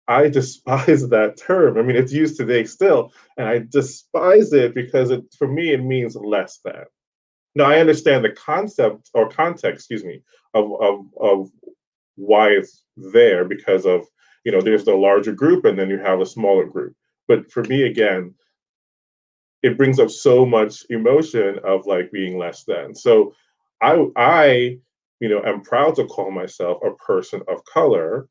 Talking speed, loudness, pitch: 170 wpm, -17 LUFS, 145 Hz